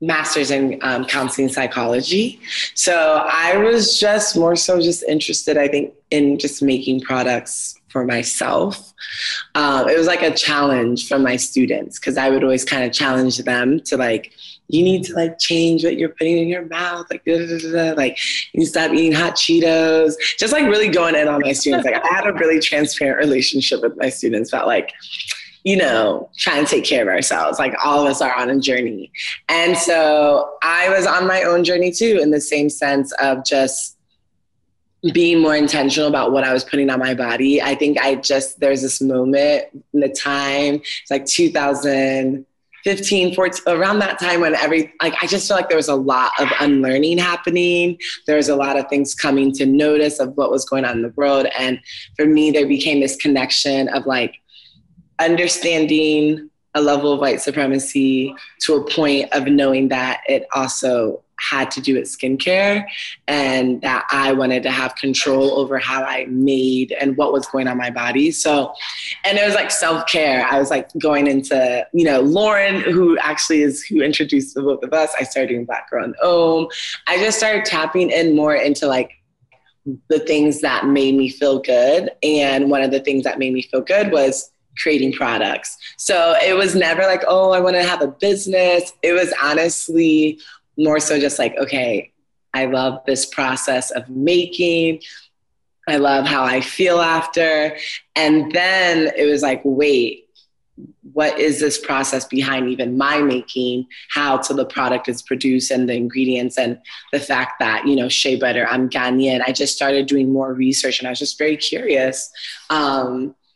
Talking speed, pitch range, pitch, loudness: 185 wpm, 135-165 Hz, 145 Hz, -17 LUFS